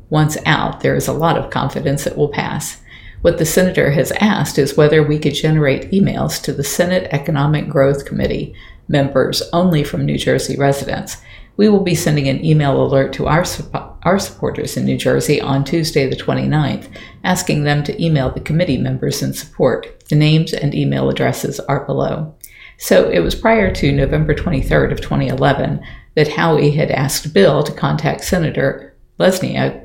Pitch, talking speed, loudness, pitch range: 150 Hz, 175 wpm, -16 LUFS, 140-170 Hz